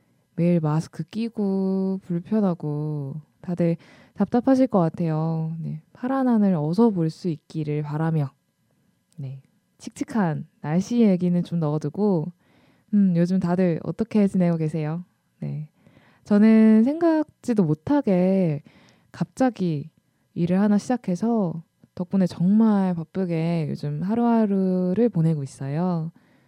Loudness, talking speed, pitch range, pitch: -23 LUFS, 240 characters per minute, 160-210 Hz, 180 Hz